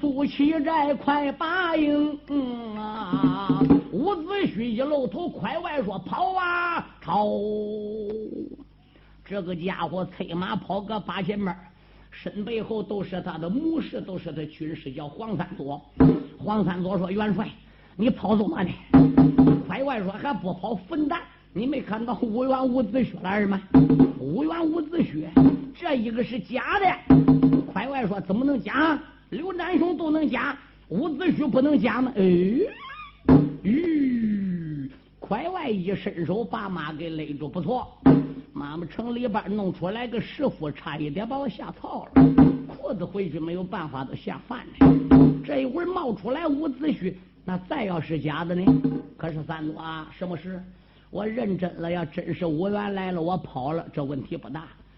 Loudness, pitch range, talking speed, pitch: -24 LUFS, 170-270 Hz, 220 characters per minute, 205 Hz